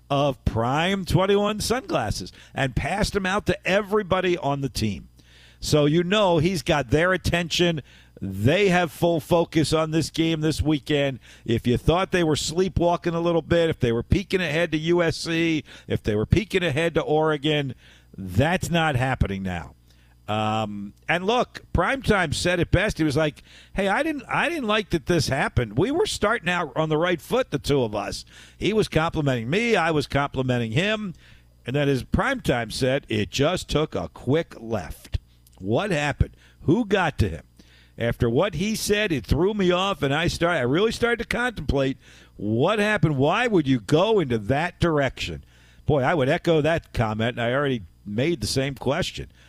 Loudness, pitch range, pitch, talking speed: -23 LUFS, 115-175 Hz, 150 Hz, 180 wpm